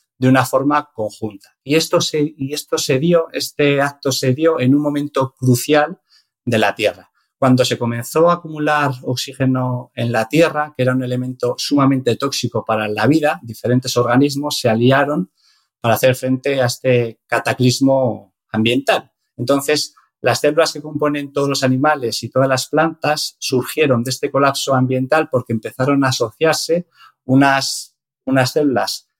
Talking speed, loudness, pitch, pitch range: 155 wpm, -17 LUFS, 135 Hz, 125-150 Hz